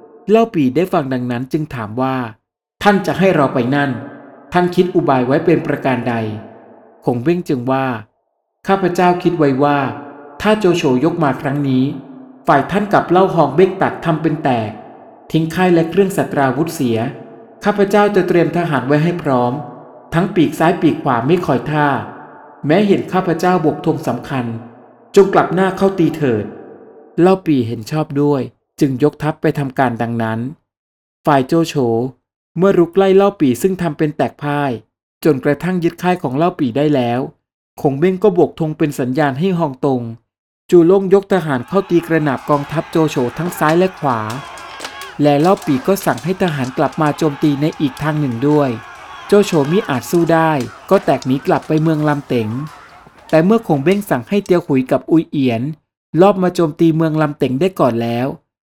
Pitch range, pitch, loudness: 135-175 Hz, 155 Hz, -15 LUFS